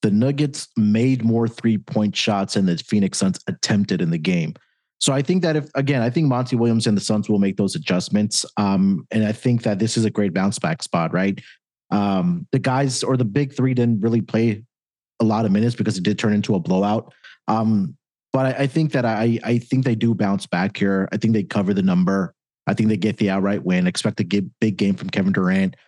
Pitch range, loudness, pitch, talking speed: 105-135 Hz, -20 LUFS, 115 Hz, 230 wpm